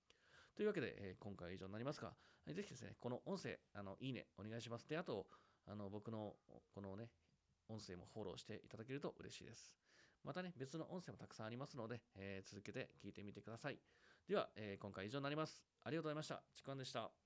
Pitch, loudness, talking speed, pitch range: 110 Hz, -52 LUFS, 425 characters per minute, 100-140 Hz